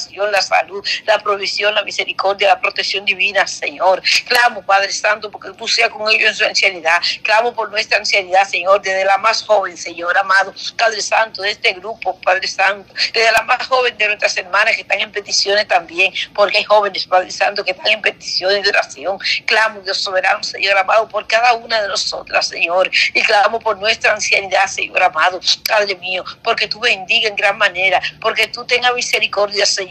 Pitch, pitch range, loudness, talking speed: 205 Hz, 195-220 Hz, -14 LUFS, 190 wpm